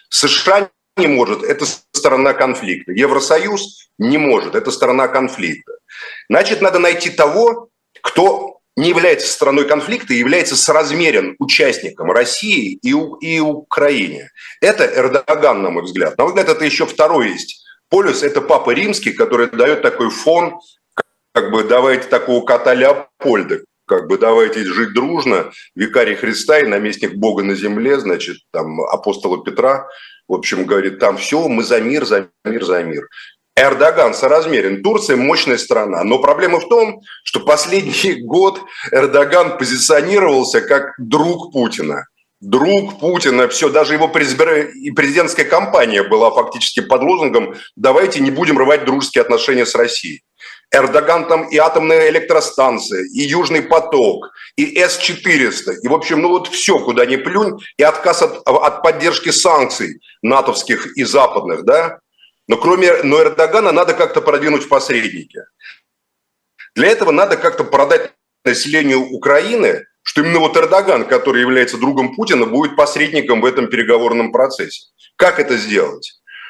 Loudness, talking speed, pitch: -13 LUFS, 140 wpm, 265 Hz